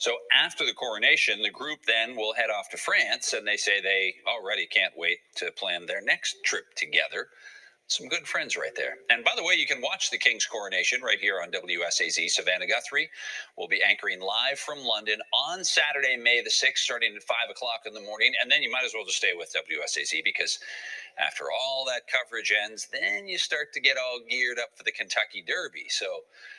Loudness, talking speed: -26 LUFS, 210 wpm